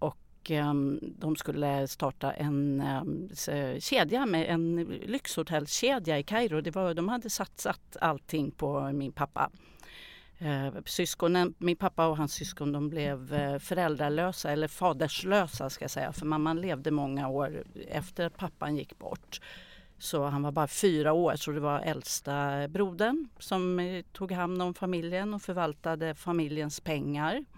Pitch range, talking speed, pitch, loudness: 145-180 Hz, 135 wpm, 155 Hz, -31 LUFS